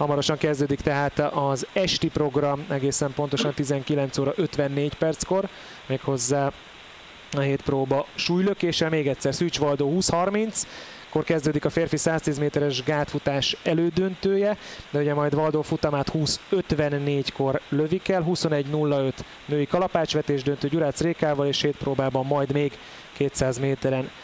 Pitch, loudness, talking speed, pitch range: 145 Hz, -25 LUFS, 125 wpm, 140-165 Hz